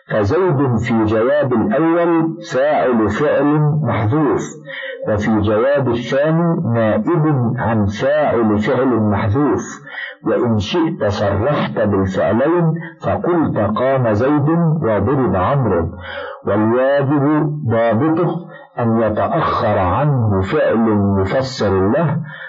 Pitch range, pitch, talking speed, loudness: 105-155 Hz, 120 Hz, 85 wpm, -16 LUFS